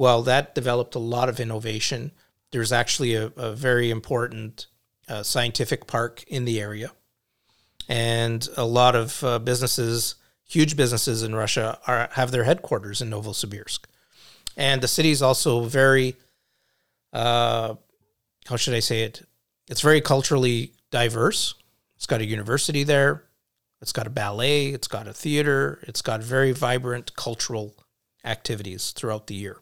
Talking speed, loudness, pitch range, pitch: 150 wpm, -23 LUFS, 115-130 Hz, 120 Hz